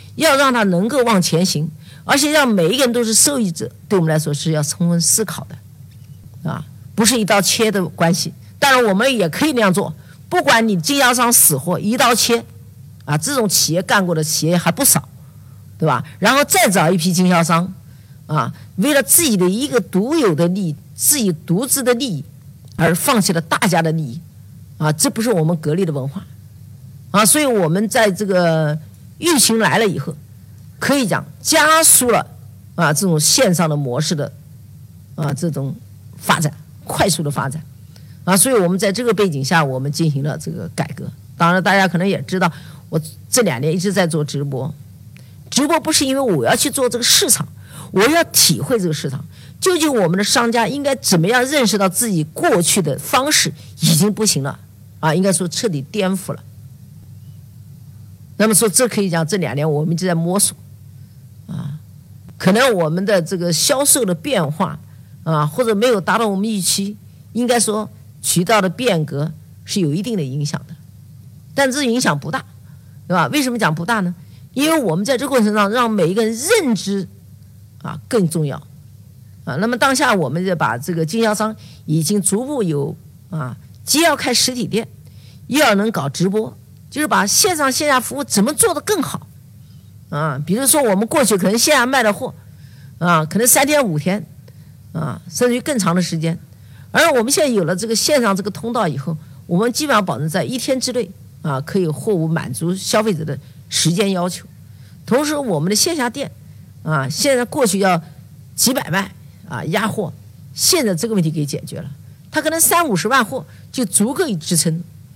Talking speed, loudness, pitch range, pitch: 270 characters per minute, -16 LUFS, 140-220 Hz, 170 Hz